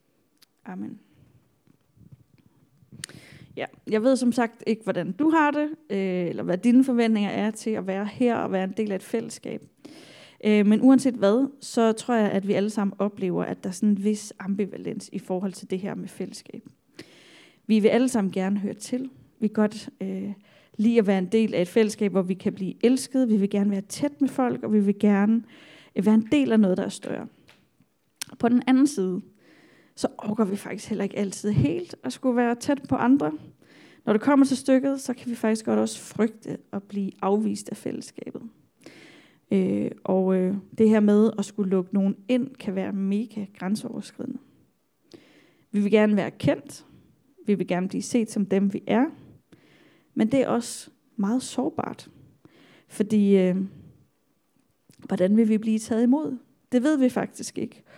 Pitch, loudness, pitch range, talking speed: 215 Hz, -24 LUFS, 200-245 Hz, 185 wpm